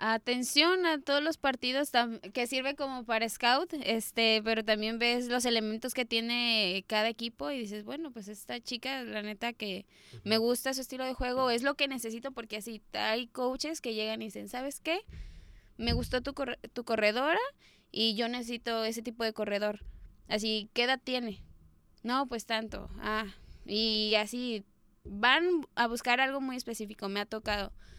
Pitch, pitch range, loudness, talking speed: 235 Hz, 220-260 Hz, -31 LUFS, 175 wpm